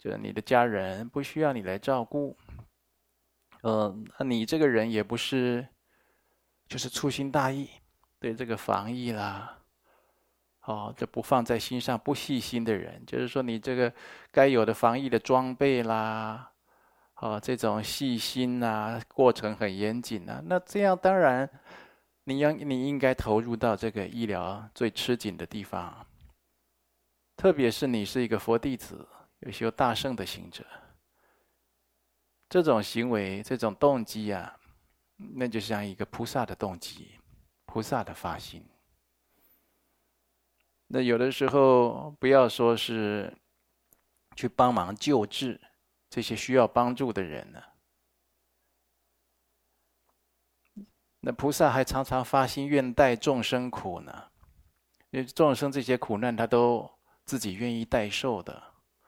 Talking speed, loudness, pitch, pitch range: 195 characters per minute, -28 LUFS, 120 Hz, 110-130 Hz